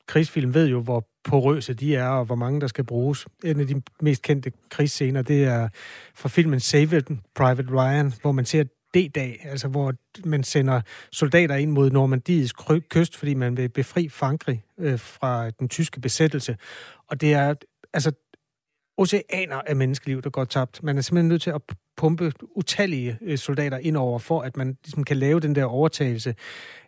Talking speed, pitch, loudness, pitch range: 180 wpm, 140 Hz, -23 LUFS, 130-155 Hz